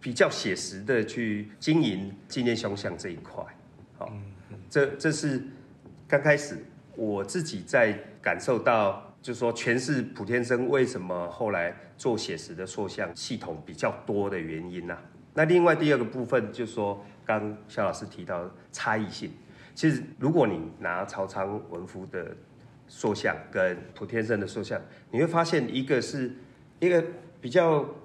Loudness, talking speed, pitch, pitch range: -28 LUFS, 230 characters per minute, 120 Hz, 100-145 Hz